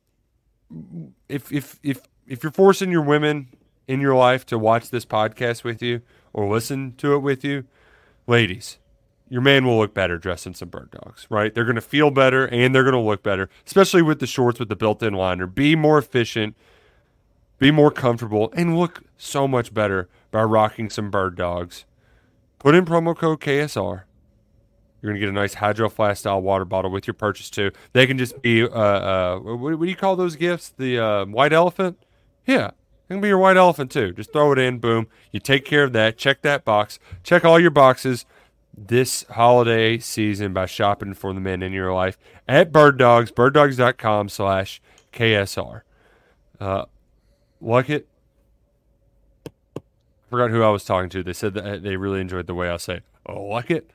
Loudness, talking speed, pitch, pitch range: -19 LUFS, 190 wpm, 115 Hz, 105-140 Hz